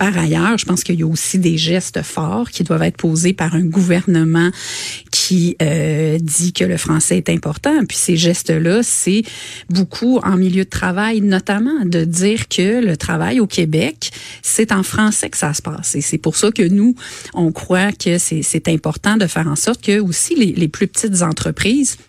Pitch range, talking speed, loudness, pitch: 160-205 Hz, 200 wpm, -15 LUFS, 180 Hz